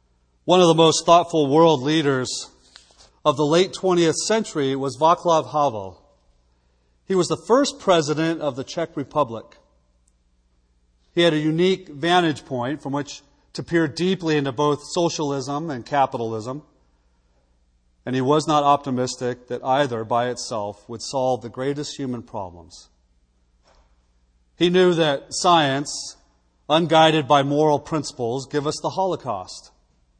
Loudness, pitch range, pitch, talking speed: -21 LUFS, 105-160 Hz, 140 Hz, 135 wpm